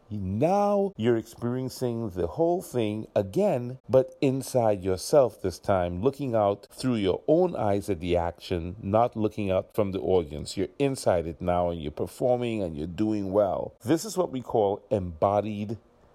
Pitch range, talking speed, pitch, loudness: 100-130 Hz, 165 wpm, 110 Hz, -27 LUFS